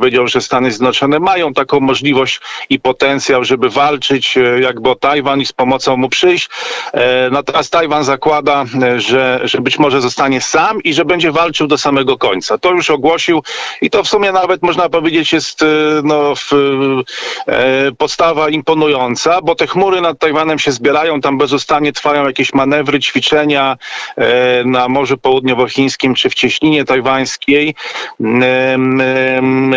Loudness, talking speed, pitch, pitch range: -12 LUFS, 155 wpm, 140 Hz, 130-155 Hz